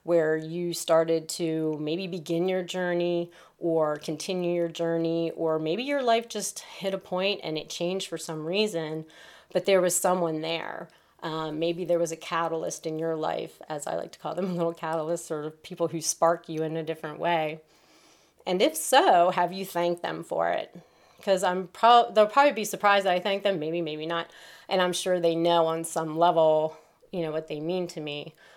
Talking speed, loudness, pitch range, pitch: 200 wpm, -27 LUFS, 160-180 Hz, 170 Hz